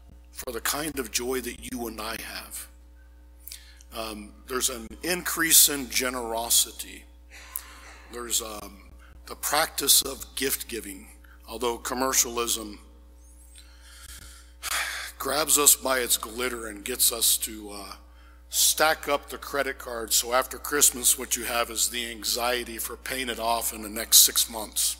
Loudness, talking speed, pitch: -24 LUFS, 140 wpm, 110 Hz